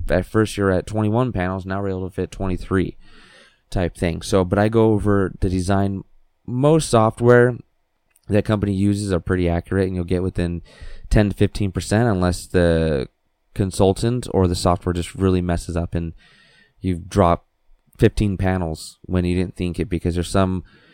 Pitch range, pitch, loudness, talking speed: 90-105 Hz, 95 Hz, -20 LUFS, 170 wpm